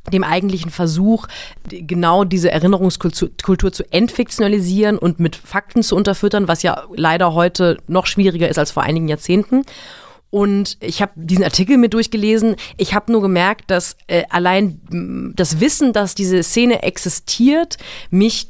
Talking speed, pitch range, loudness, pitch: 150 wpm, 175-210 Hz, -16 LUFS, 190 Hz